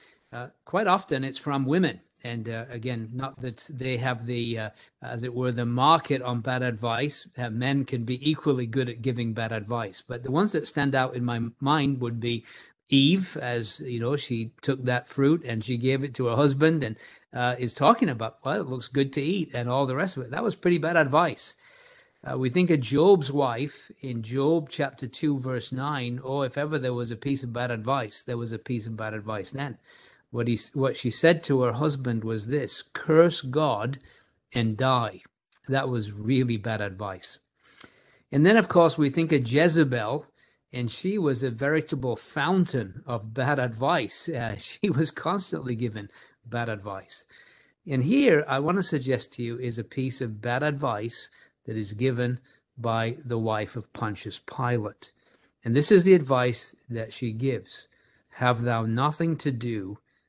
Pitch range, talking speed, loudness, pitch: 120-145 Hz, 190 wpm, -26 LUFS, 130 Hz